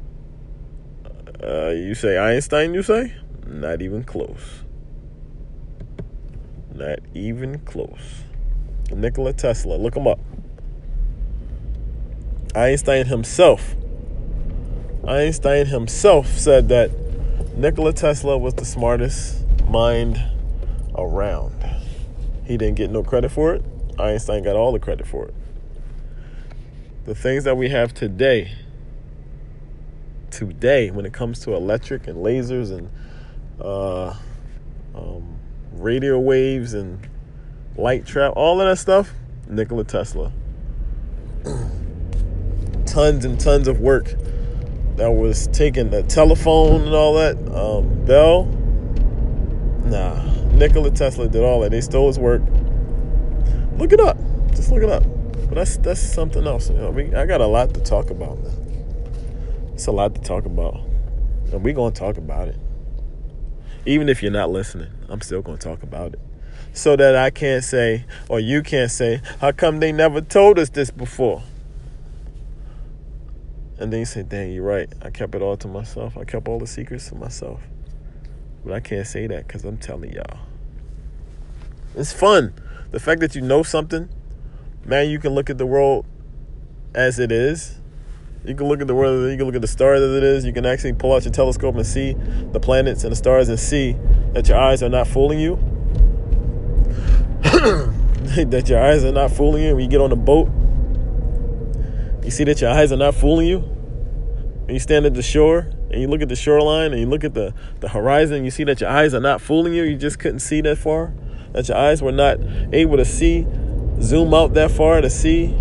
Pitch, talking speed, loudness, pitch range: 125 Hz, 165 wpm, -19 LUFS, 110-145 Hz